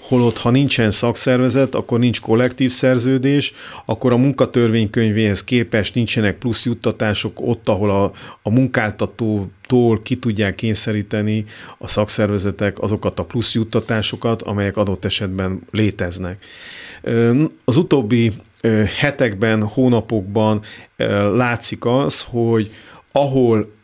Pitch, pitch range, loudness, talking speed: 115 Hz, 105-125 Hz, -17 LUFS, 105 wpm